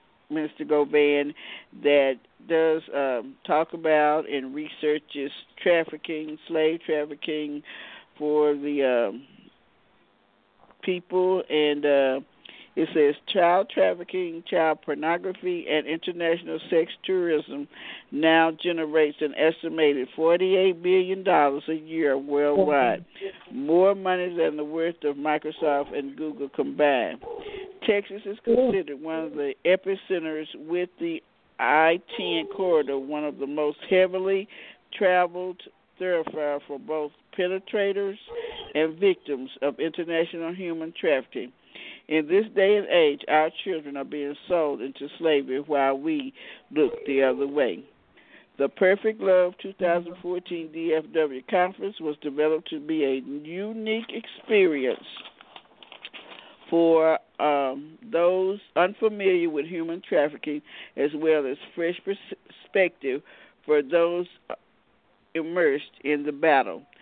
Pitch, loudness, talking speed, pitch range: 160 Hz, -25 LUFS, 115 wpm, 150-185 Hz